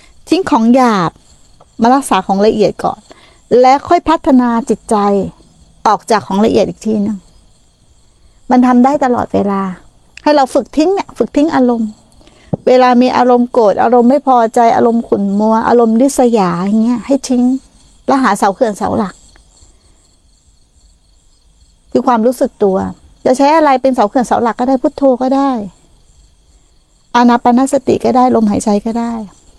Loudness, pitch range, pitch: -11 LUFS, 200-260 Hz, 235 Hz